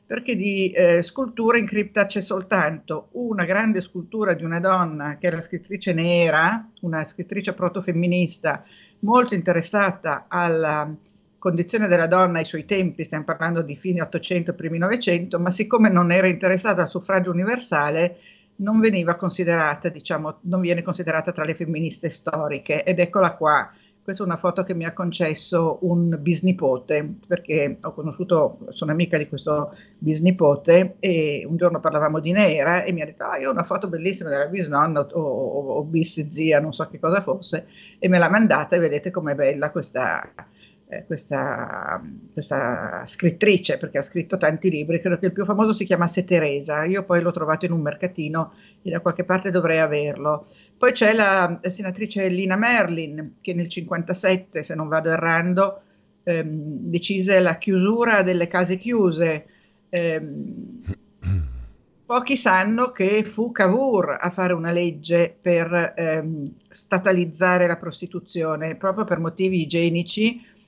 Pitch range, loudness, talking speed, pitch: 160-190 Hz, -21 LUFS, 155 wpm, 175 Hz